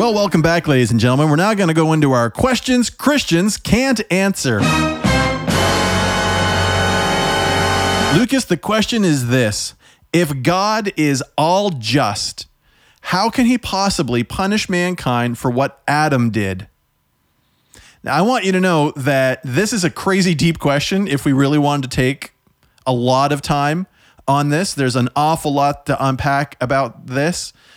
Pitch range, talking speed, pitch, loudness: 125-185 Hz, 150 wpm, 145 Hz, -16 LUFS